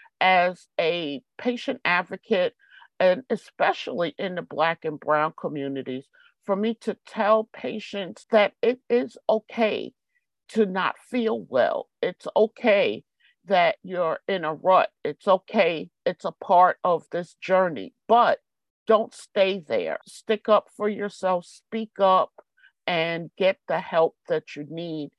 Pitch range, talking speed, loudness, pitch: 170-230 Hz, 135 wpm, -24 LUFS, 195 Hz